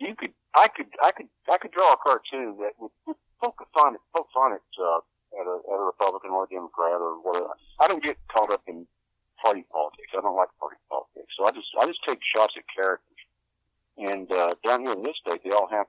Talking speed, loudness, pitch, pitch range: 235 wpm, -25 LUFS, 100 Hz, 90-125 Hz